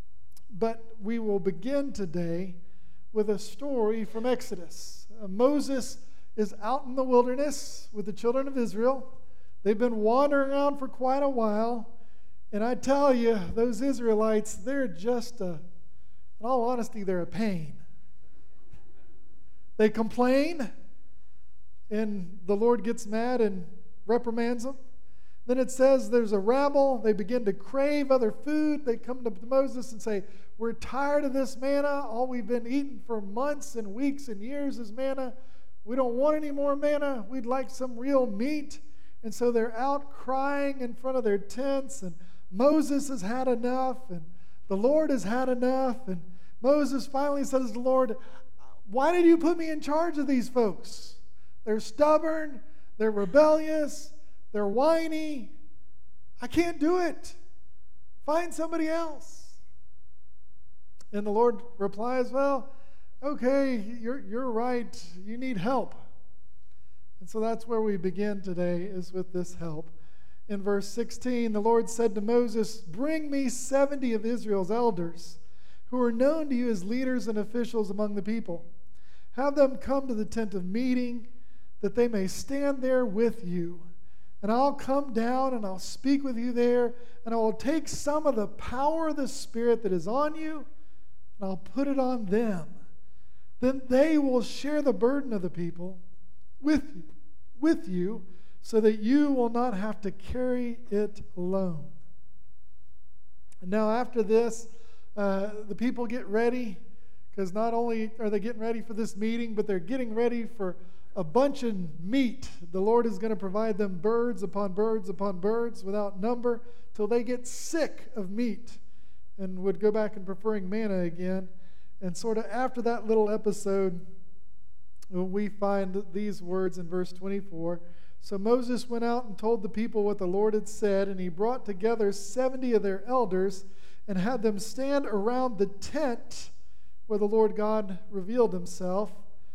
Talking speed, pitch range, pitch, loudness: 160 wpm, 200-260 Hz, 230 Hz, -29 LUFS